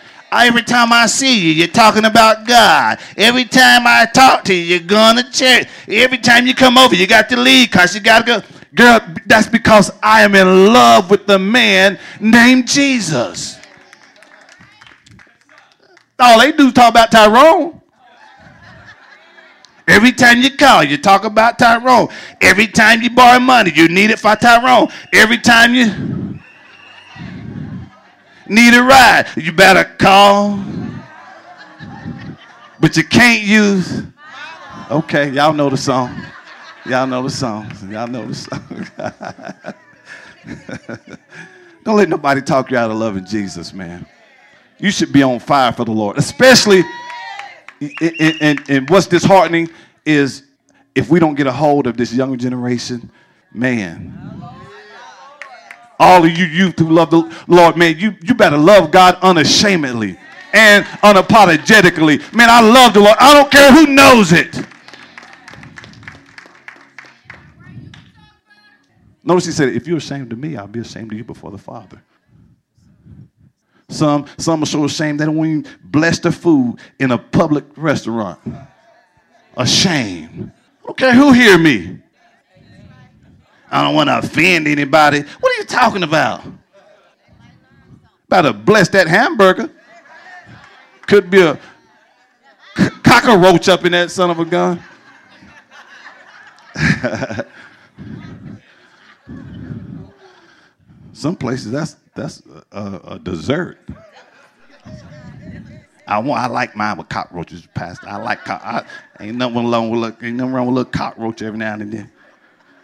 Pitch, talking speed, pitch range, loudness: 185 Hz, 135 wpm, 145-235 Hz, -10 LUFS